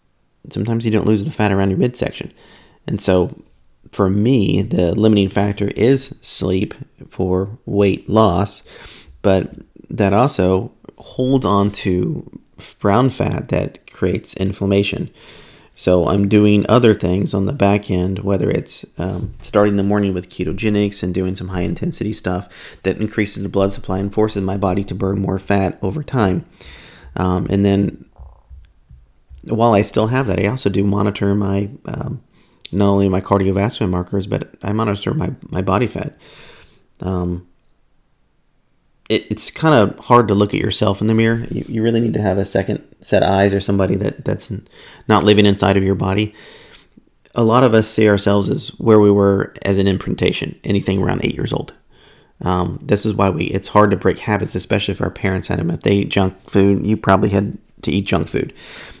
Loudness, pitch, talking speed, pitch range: -17 LUFS, 100 Hz, 180 wpm, 95-105 Hz